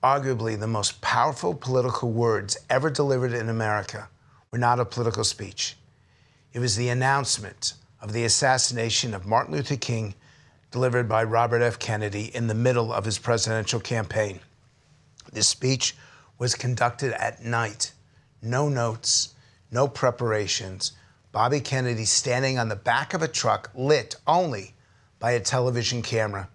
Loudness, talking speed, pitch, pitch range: -25 LUFS, 140 wpm, 120 Hz, 110-130 Hz